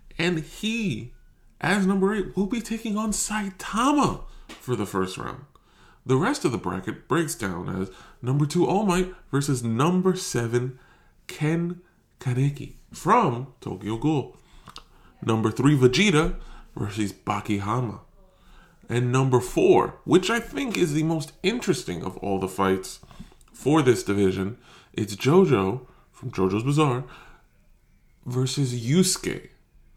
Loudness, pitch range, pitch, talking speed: -24 LUFS, 120-180 Hz, 140 Hz, 125 wpm